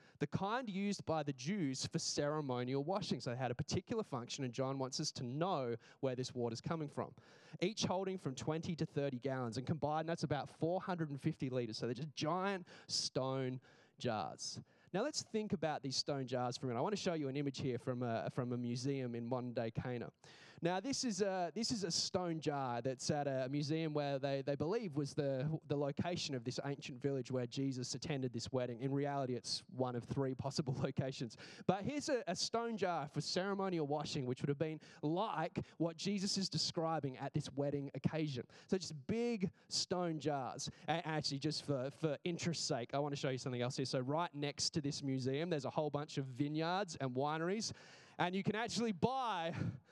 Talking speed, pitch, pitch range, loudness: 205 wpm, 150 Hz, 135-170 Hz, -40 LUFS